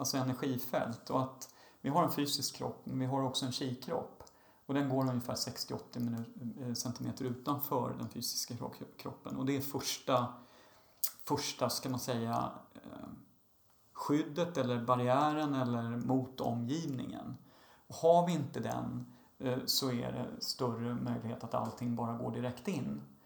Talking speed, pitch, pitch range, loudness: 140 wpm, 125 Hz, 120-135 Hz, -36 LUFS